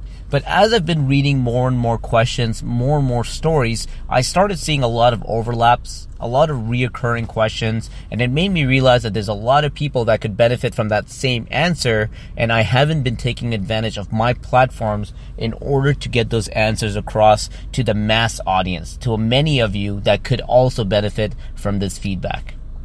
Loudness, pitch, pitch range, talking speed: -18 LUFS, 115 Hz, 110-130 Hz, 195 wpm